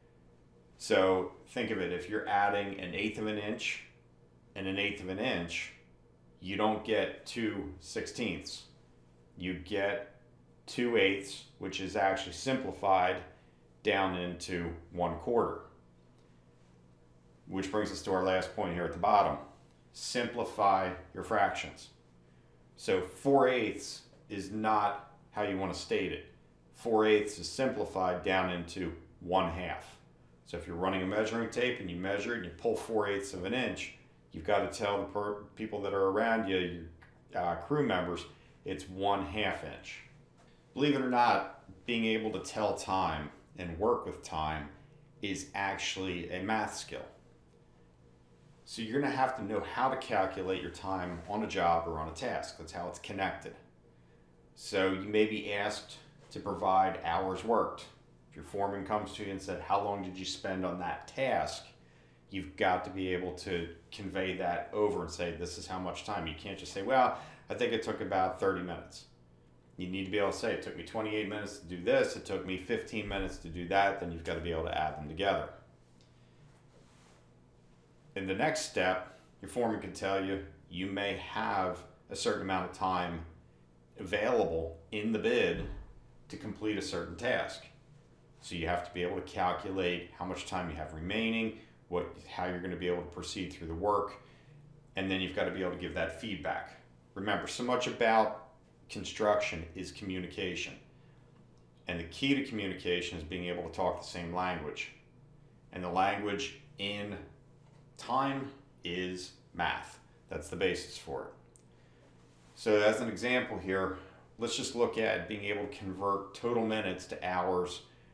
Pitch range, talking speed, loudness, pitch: 85-105 Hz, 175 wpm, -34 LUFS, 95 Hz